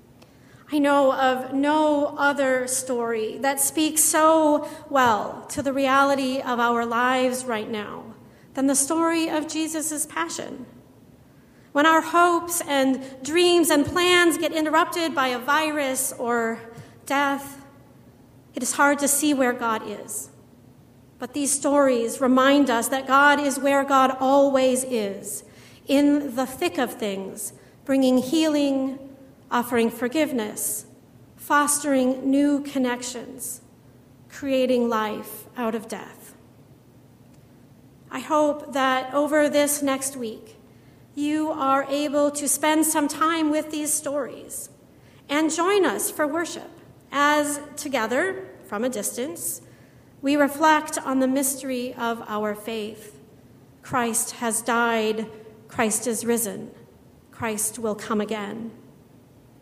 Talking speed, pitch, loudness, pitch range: 120 wpm, 270 Hz, -22 LUFS, 235-295 Hz